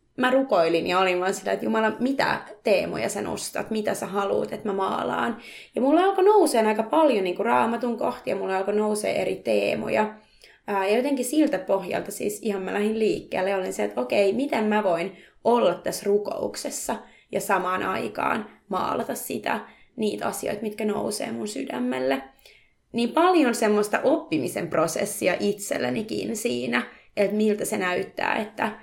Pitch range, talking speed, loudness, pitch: 195-240 Hz, 160 wpm, -25 LUFS, 210 Hz